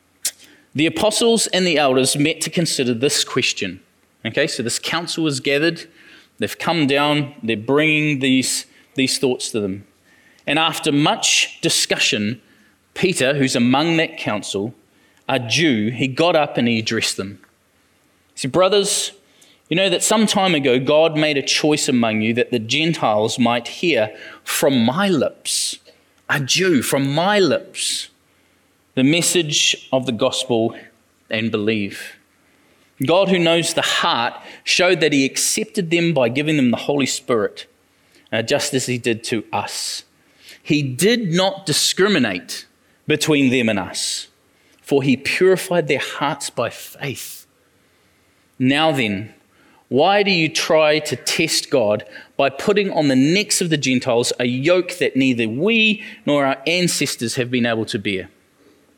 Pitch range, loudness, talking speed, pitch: 125-170 Hz, -18 LUFS, 150 wpm, 145 Hz